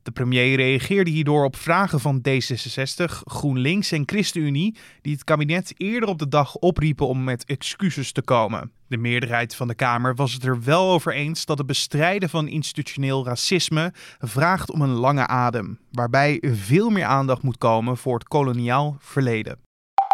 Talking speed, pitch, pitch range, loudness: 165 wpm, 140 Hz, 125-160 Hz, -22 LUFS